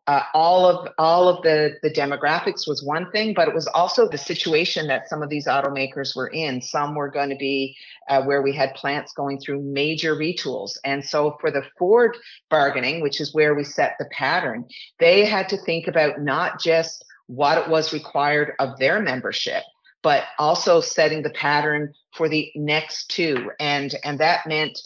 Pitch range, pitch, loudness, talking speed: 140-160 Hz, 150 Hz, -21 LUFS, 190 wpm